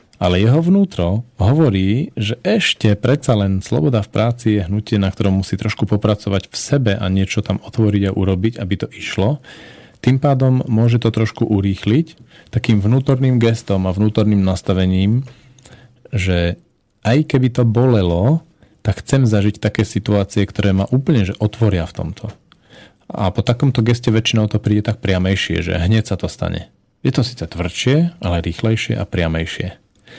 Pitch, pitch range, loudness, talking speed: 110 Hz, 100-120 Hz, -17 LUFS, 160 wpm